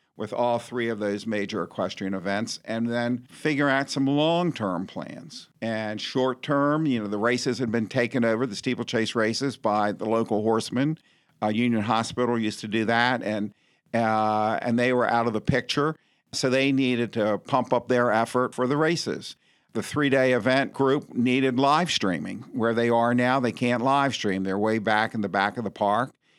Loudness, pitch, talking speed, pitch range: -25 LUFS, 120 Hz, 195 wpm, 110-130 Hz